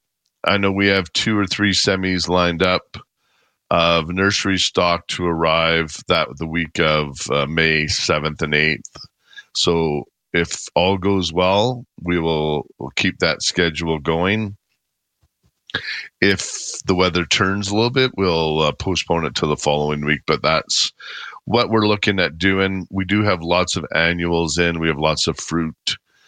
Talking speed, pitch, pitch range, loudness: 160 wpm, 90 Hz, 80-100 Hz, -18 LUFS